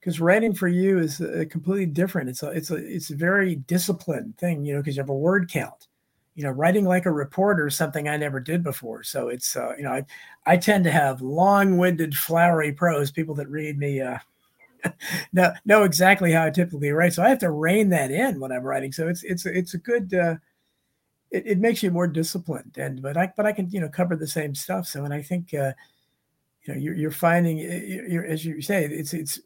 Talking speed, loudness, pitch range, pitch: 235 wpm, -23 LUFS, 150-185 Hz, 170 Hz